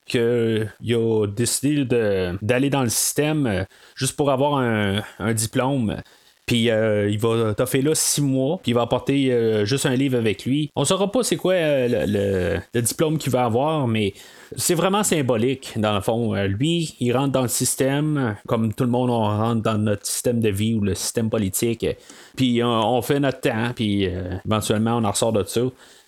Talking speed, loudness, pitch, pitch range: 210 wpm, -21 LUFS, 120 Hz, 110-135 Hz